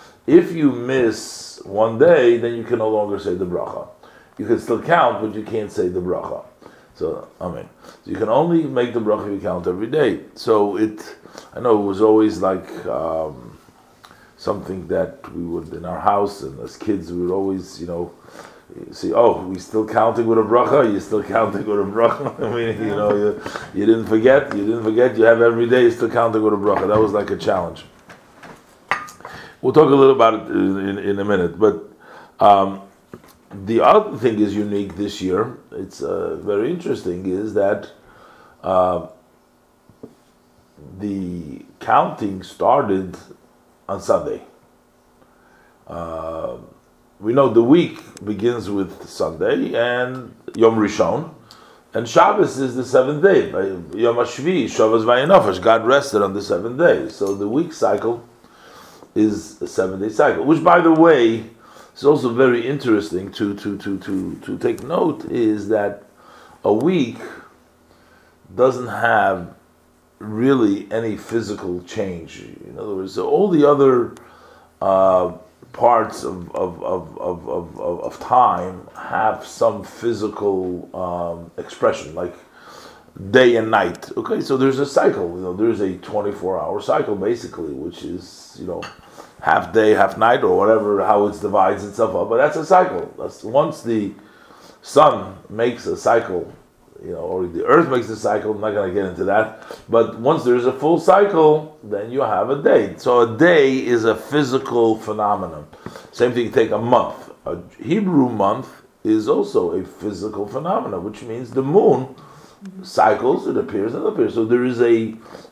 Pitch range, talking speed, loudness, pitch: 100-125 Hz, 165 wpm, -18 LUFS, 110 Hz